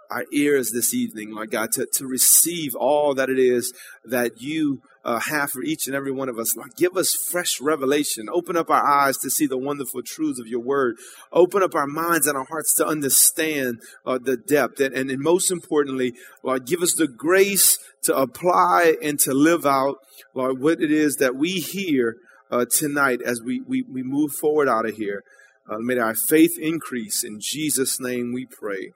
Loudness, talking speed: -21 LUFS, 200 wpm